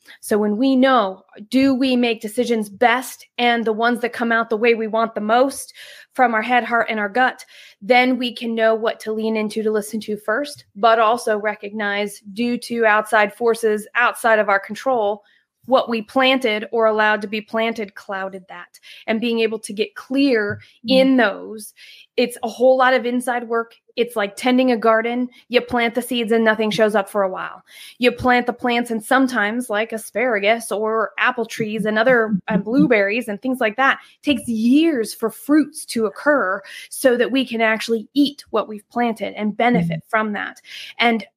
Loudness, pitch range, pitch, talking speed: -19 LUFS, 215-245 Hz, 230 Hz, 190 wpm